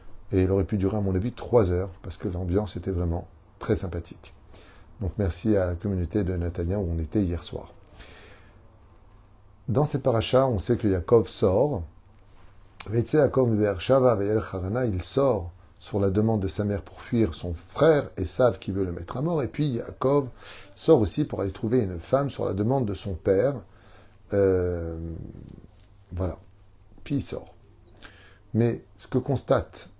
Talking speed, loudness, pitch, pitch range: 175 wpm, -26 LUFS, 100 Hz, 95-115 Hz